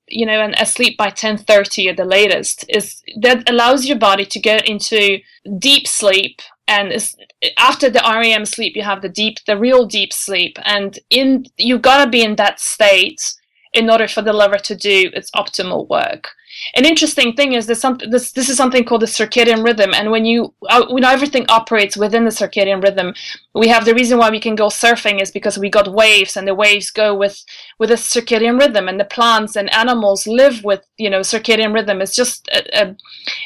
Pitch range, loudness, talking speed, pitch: 205-245 Hz, -13 LUFS, 205 wpm, 220 Hz